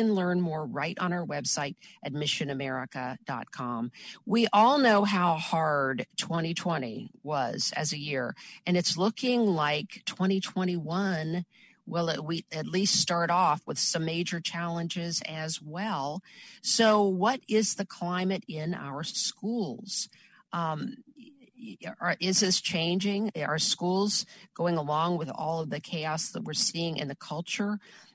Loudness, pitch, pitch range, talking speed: -28 LUFS, 180 Hz, 160-210 Hz, 130 wpm